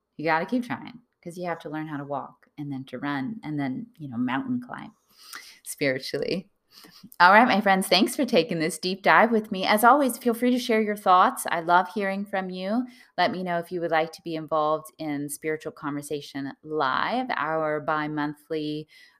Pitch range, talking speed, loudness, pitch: 150-205 Hz, 205 wpm, -25 LUFS, 165 Hz